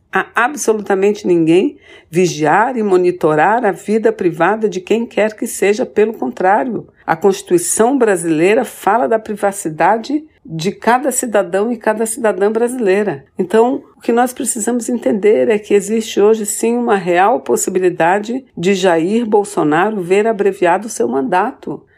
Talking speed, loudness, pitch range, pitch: 140 wpm, -14 LUFS, 195-240 Hz, 215 Hz